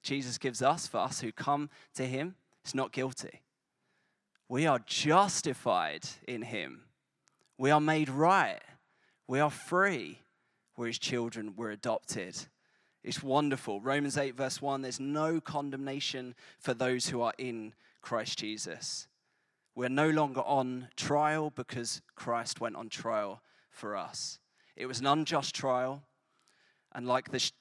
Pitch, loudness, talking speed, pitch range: 130 Hz, -33 LUFS, 140 wpm, 125-145 Hz